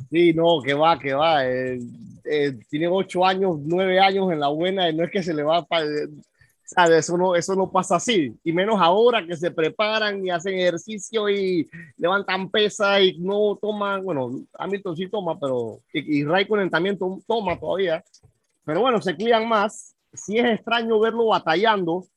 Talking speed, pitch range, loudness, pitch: 185 wpm, 165-205 Hz, -22 LUFS, 185 Hz